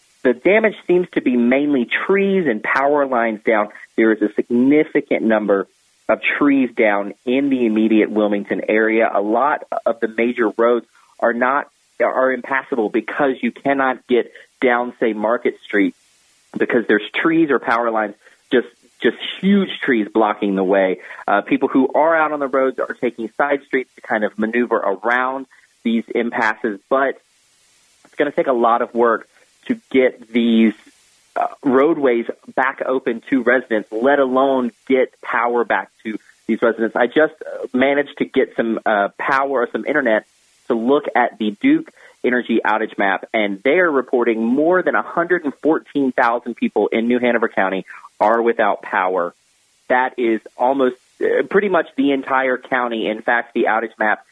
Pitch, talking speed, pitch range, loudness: 125 Hz, 160 wpm, 115-140 Hz, -18 LUFS